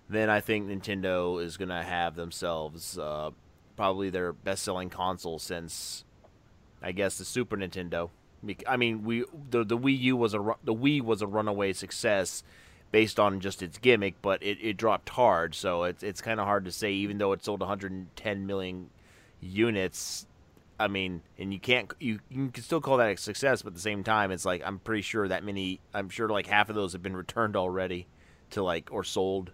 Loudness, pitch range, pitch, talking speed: -30 LUFS, 90-110 Hz, 95 Hz, 200 wpm